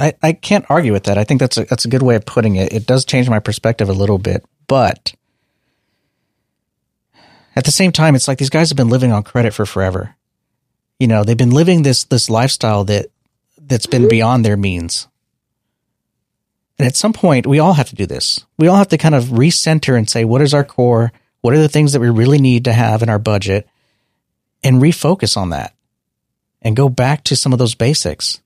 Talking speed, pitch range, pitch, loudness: 215 wpm, 110-145 Hz, 125 Hz, -13 LUFS